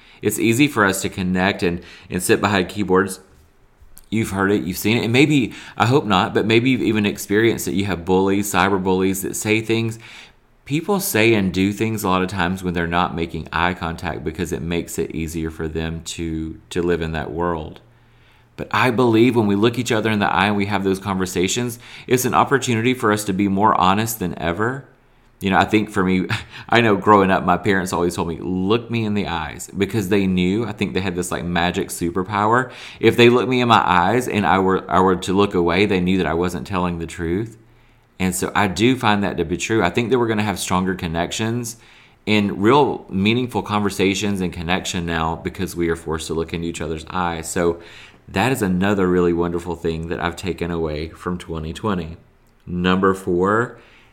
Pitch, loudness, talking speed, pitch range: 95 Hz, -19 LUFS, 215 wpm, 85-110 Hz